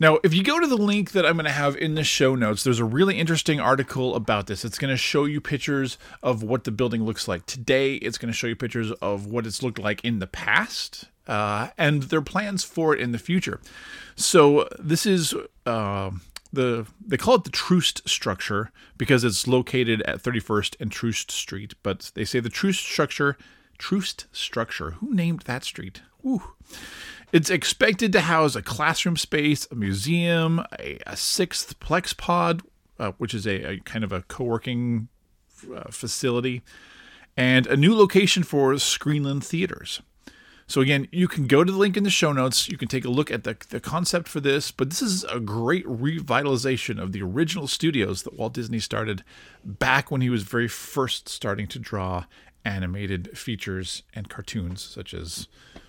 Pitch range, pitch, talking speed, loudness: 110-160 Hz, 130 Hz, 190 wpm, -24 LUFS